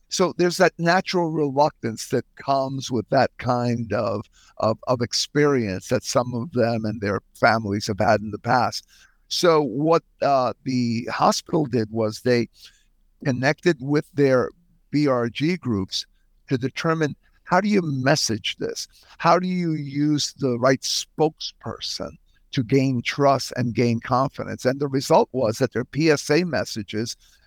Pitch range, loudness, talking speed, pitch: 115-150 Hz, -22 LUFS, 145 wpm, 135 Hz